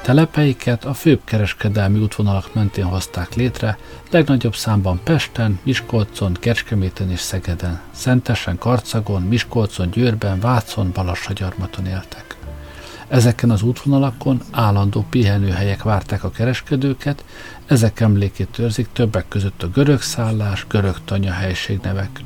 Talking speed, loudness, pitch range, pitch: 110 wpm, -19 LUFS, 95-120 Hz, 110 Hz